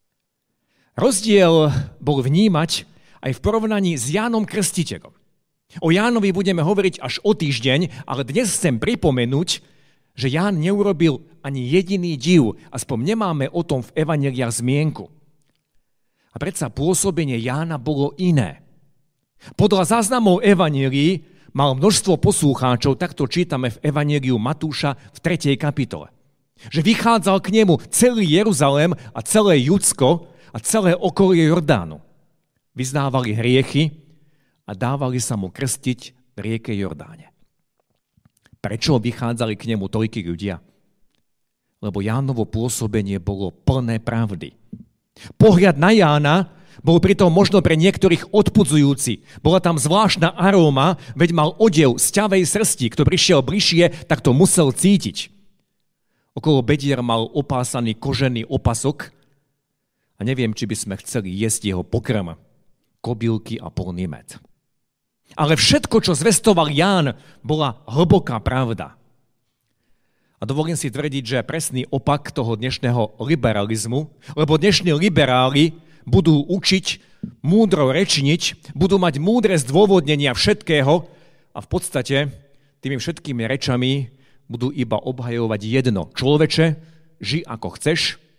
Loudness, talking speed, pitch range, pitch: -18 LUFS, 120 wpm, 125-175 Hz, 145 Hz